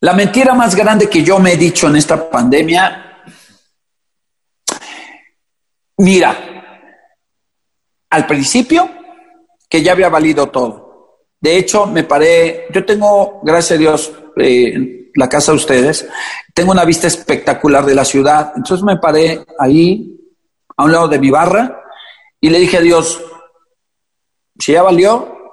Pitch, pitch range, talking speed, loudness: 170 Hz, 155-200 Hz, 140 wpm, -11 LUFS